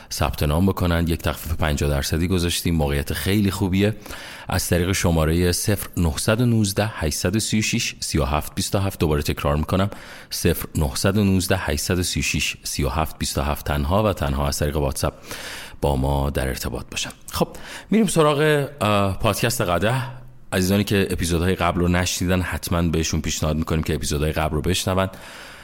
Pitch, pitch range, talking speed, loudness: 90 Hz, 80-100 Hz, 130 wpm, -22 LUFS